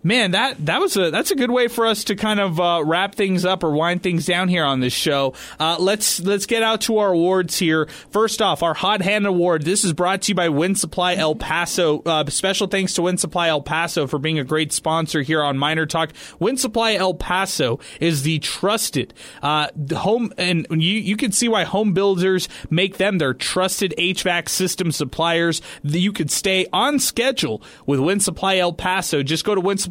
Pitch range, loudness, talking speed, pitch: 160-195 Hz, -19 LUFS, 215 wpm, 180 Hz